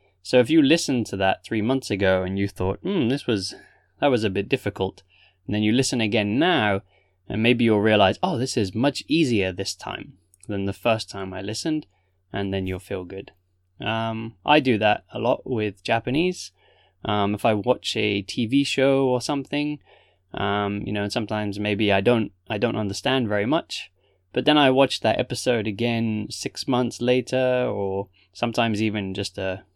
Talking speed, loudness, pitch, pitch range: 190 wpm, -23 LUFS, 105 Hz, 100-125 Hz